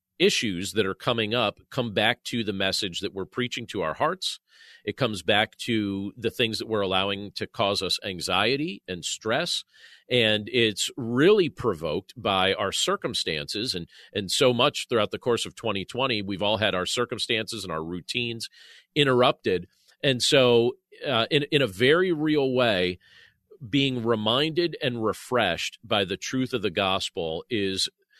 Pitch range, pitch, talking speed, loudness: 100-130 Hz, 115 Hz, 160 wpm, -25 LUFS